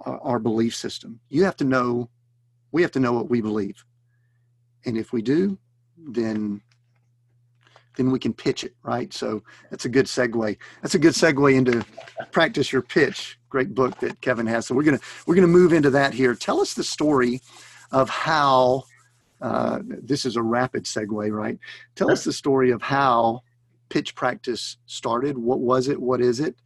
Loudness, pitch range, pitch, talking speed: -22 LUFS, 120-130 Hz, 120 Hz, 180 wpm